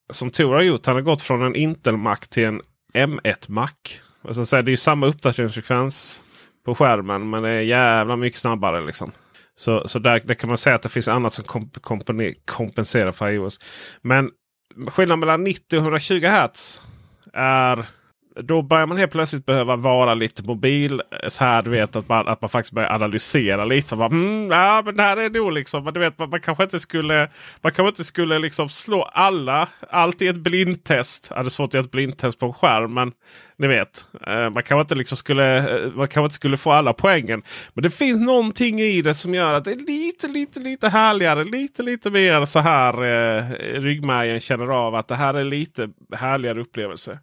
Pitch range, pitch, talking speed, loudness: 120-165 Hz, 135 Hz, 195 wpm, -20 LUFS